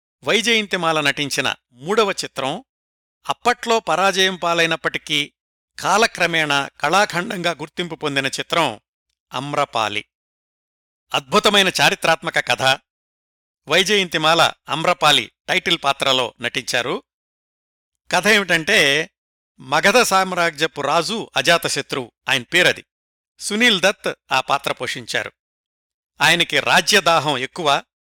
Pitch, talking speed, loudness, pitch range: 160 Hz, 80 wpm, -18 LUFS, 135-180 Hz